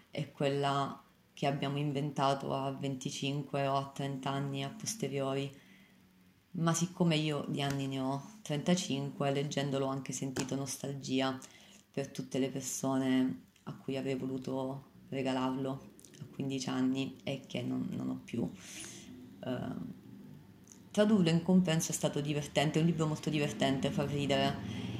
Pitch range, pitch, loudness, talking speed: 135-145 Hz, 140 Hz, -35 LUFS, 140 wpm